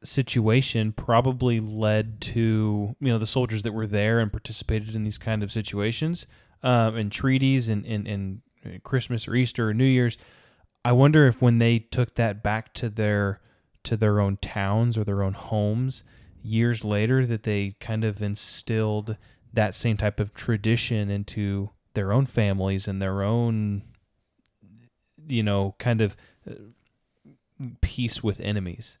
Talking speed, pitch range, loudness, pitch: 155 wpm, 105-120 Hz, -25 LUFS, 110 Hz